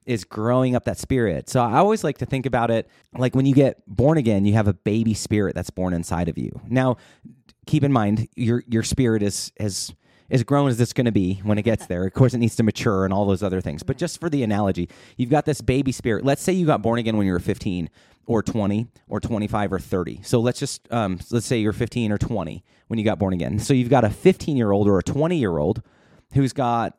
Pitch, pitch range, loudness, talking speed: 115 Hz, 100-130 Hz, -22 LUFS, 260 wpm